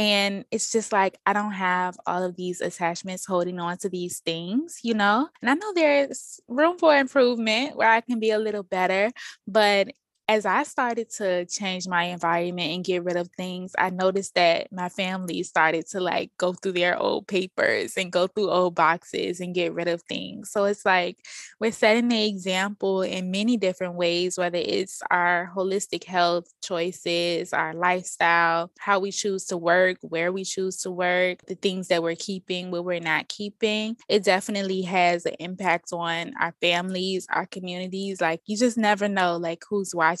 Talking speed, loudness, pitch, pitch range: 185 wpm, -24 LUFS, 185 Hz, 175-205 Hz